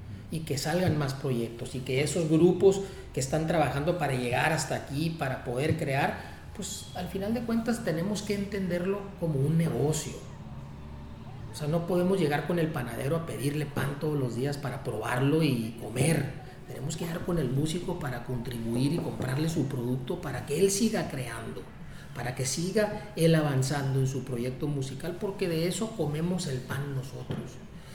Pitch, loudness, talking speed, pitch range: 145 Hz, -30 LUFS, 175 wpm, 130-170 Hz